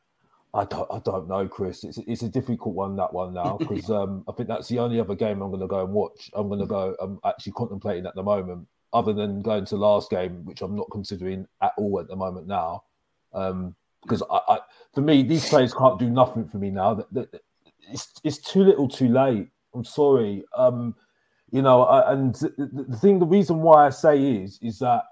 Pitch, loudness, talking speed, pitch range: 115 Hz, -23 LUFS, 215 wpm, 100-135 Hz